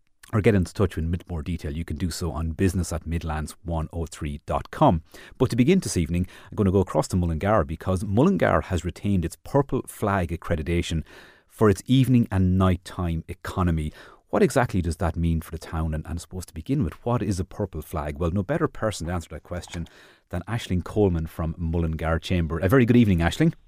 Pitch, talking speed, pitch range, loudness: 90 Hz, 205 wpm, 80-100 Hz, -25 LUFS